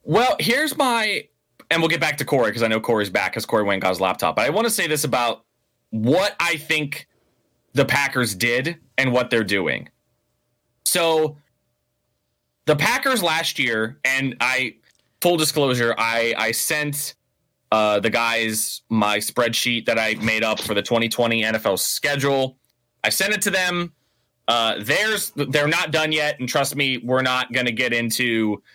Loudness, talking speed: -20 LUFS, 175 wpm